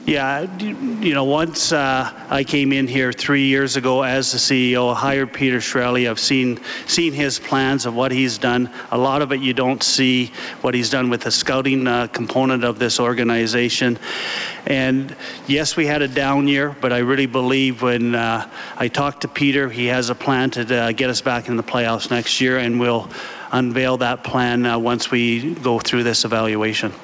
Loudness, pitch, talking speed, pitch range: -18 LUFS, 130 Hz, 200 wpm, 120-135 Hz